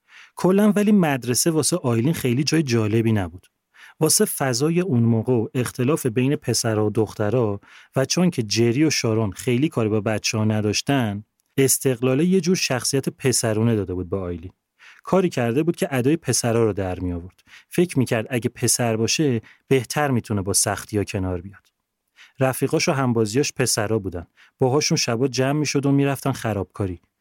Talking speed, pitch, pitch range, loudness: 170 wpm, 125 Hz, 110-145 Hz, -21 LUFS